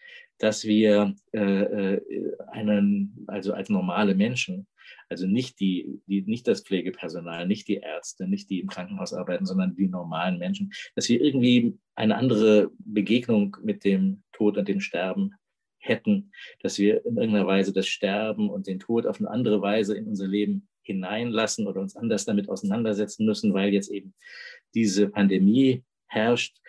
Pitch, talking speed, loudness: 110 Hz, 155 wpm, -25 LUFS